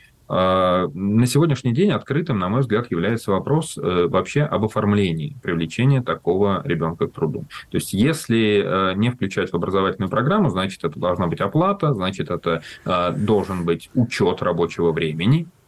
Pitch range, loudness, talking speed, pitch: 90-135 Hz, -21 LUFS, 140 wpm, 105 Hz